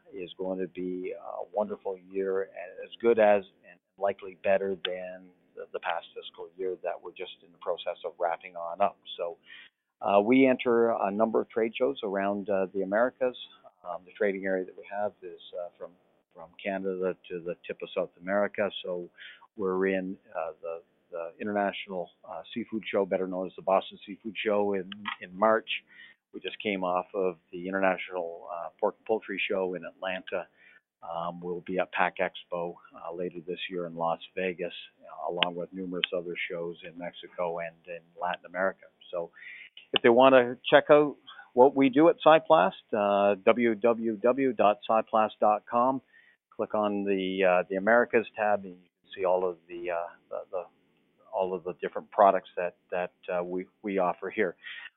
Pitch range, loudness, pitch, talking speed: 90-115 Hz, -29 LUFS, 95 Hz, 175 wpm